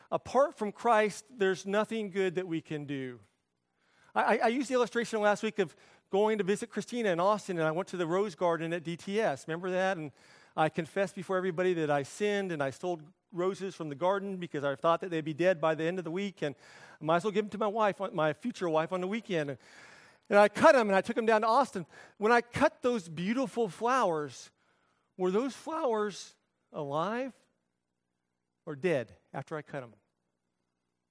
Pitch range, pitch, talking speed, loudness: 155-215 Hz, 185 Hz, 205 wpm, -31 LUFS